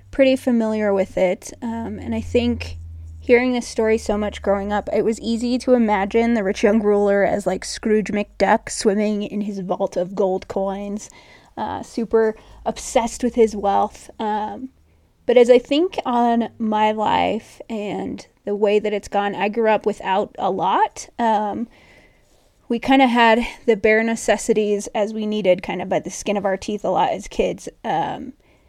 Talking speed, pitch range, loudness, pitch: 180 wpm, 200-235 Hz, -20 LUFS, 215 Hz